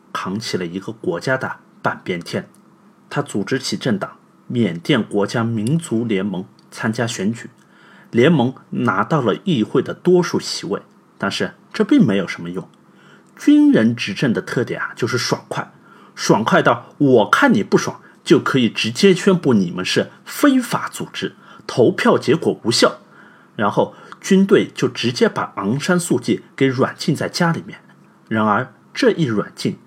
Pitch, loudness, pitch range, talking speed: 170 Hz, -18 LUFS, 120-195 Hz, 230 characters per minute